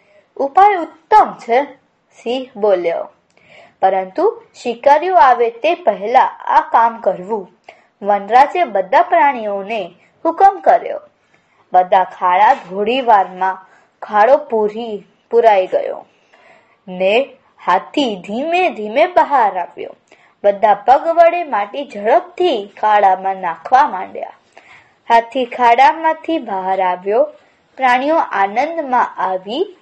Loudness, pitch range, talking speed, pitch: -14 LUFS, 205-320 Hz, 95 wpm, 245 Hz